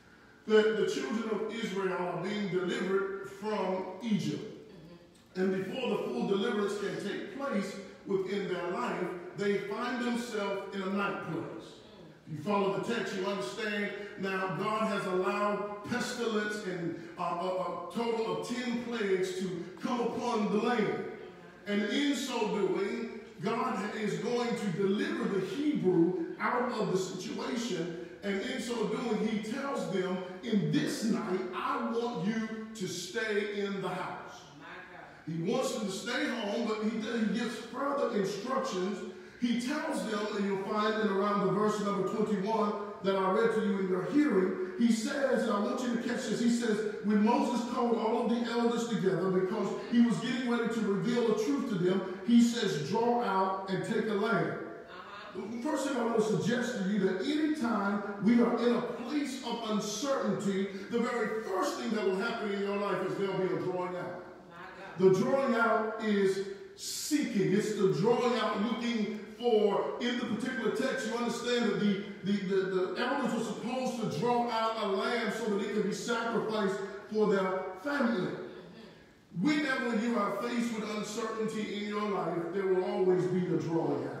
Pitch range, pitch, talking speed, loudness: 190-235 Hz, 210 Hz, 175 wpm, -32 LUFS